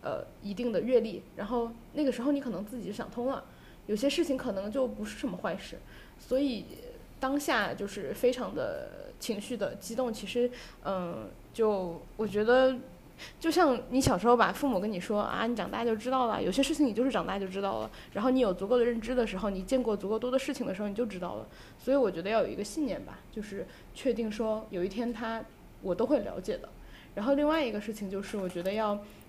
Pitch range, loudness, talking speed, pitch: 205-260 Hz, -31 LUFS, 325 characters per minute, 235 Hz